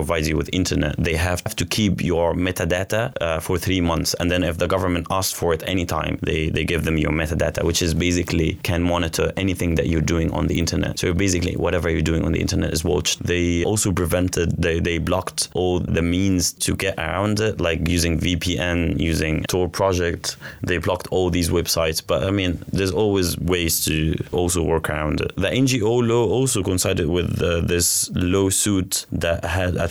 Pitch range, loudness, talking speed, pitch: 85-95 Hz, -21 LUFS, 195 wpm, 90 Hz